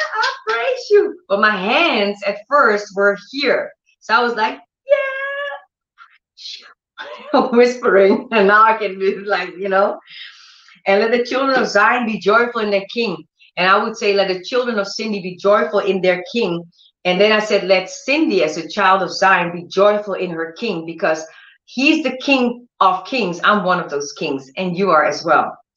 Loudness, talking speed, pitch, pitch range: -16 LUFS, 185 wpm, 205 Hz, 190-245 Hz